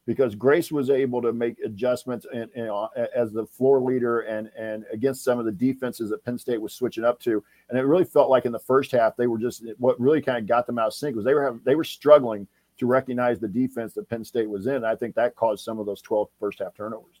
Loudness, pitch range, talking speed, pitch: -24 LUFS, 110-130 Hz, 270 wpm, 120 Hz